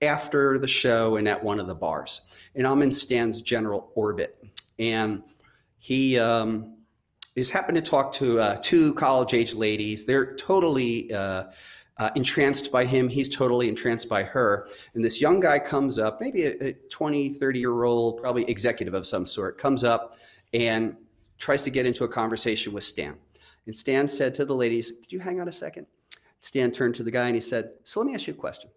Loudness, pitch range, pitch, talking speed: -25 LUFS, 115-135 Hz, 120 Hz, 200 wpm